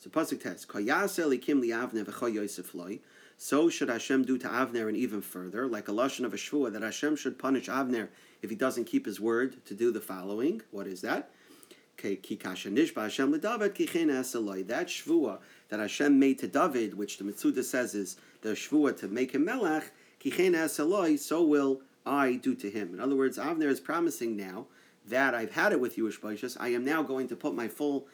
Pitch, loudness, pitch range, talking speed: 130 Hz, -31 LUFS, 115-155 Hz, 175 wpm